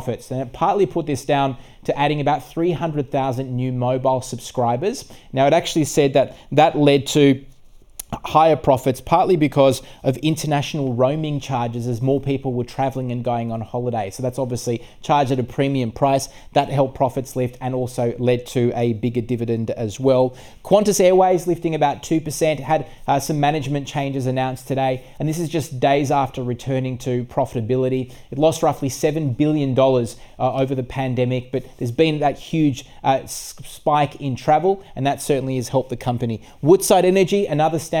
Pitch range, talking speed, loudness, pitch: 125-150 Hz, 175 wpm, -20 LUFS, 135 Hz